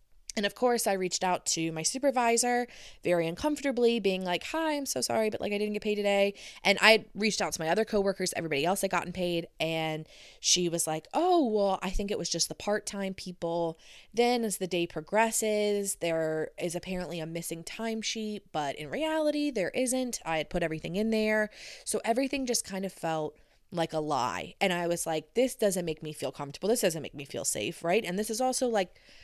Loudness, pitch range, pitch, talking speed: -30 LUFS, 170-220 Hz, 195 Hz, 215 wpm